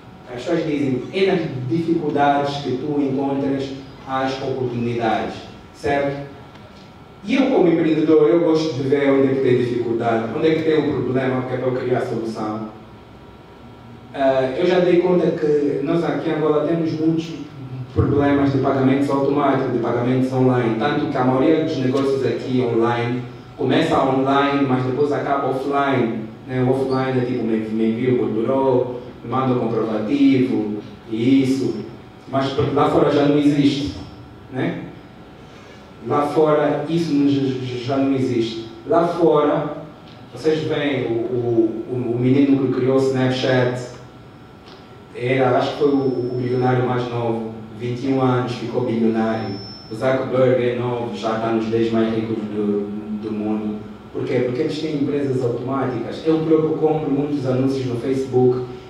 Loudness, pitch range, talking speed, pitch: -19 LUFS, 120-145 Hz, 150 wpm, 130 Hz